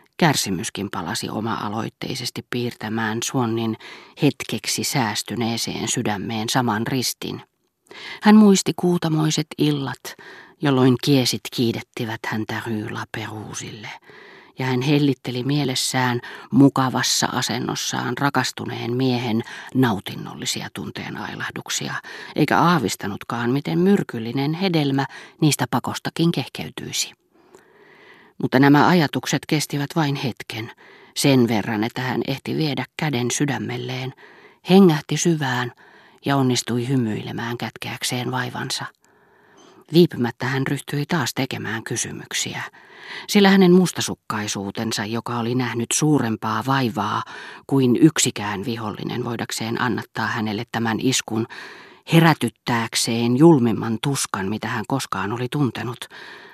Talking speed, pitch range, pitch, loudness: 95 wpm, 115-140 Hz, 125 Hz, -21 LUFS